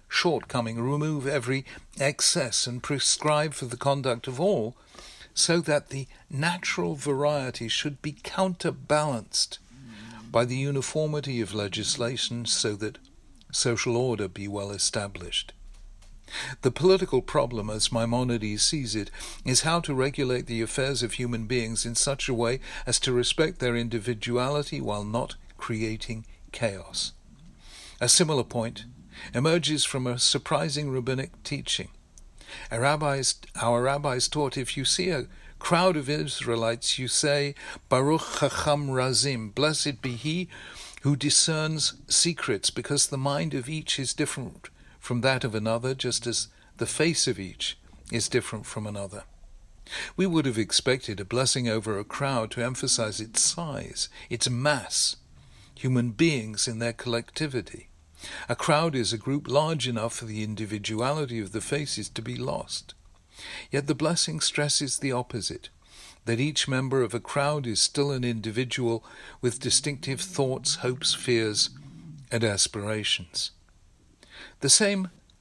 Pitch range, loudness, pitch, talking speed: 115-145 Hz, -26 LUFS, 125 Hz, 140 wpm